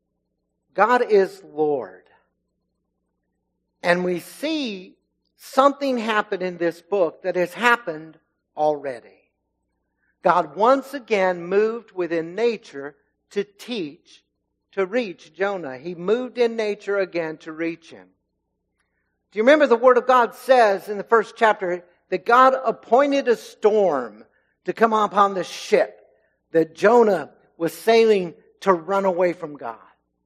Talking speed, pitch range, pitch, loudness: 130 wpm, 160-225 Hz, 185 Hz, -21 LUFS